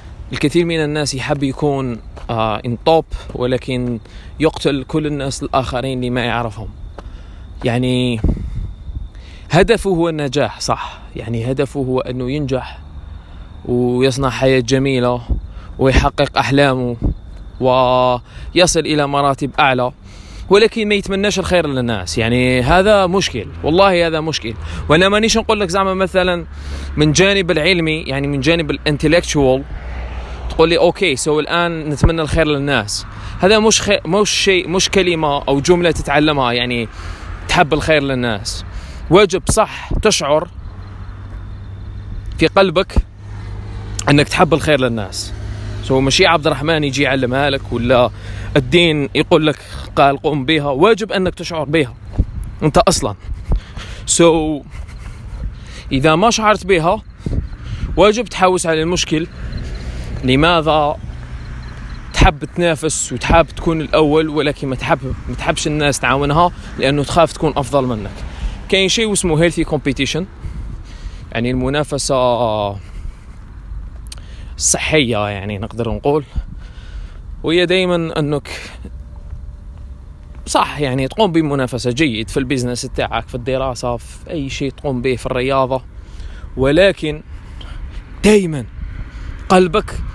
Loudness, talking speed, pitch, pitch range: -15 LUFS, 115 wpm, 135 Hz, 105-160 Hz